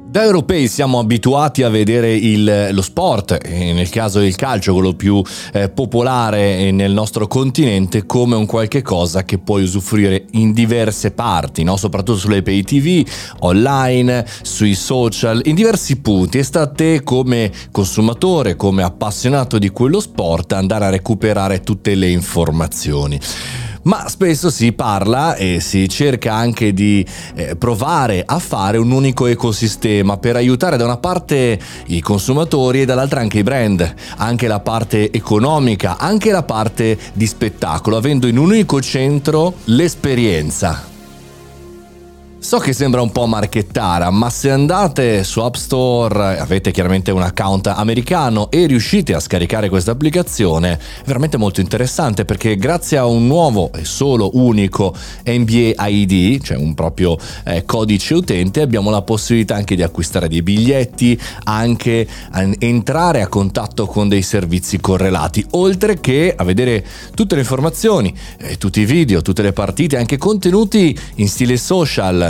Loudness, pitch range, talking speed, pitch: -15 LUFS, 95-130 Hz, 150 wpm, 110 Hz